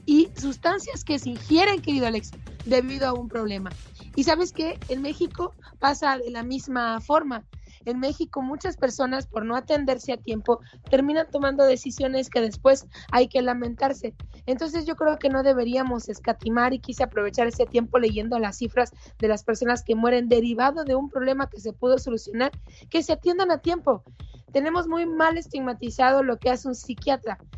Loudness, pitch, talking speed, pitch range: -24 LUFS, 260 Hz, 175 wpm, 240-285 Hz